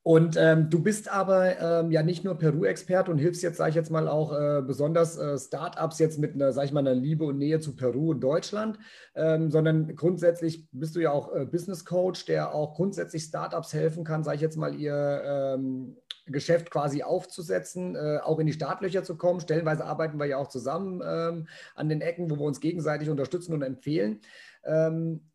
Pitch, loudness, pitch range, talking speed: 160 Hz, -28 LUFS, 150-170 Hz, 205 wpm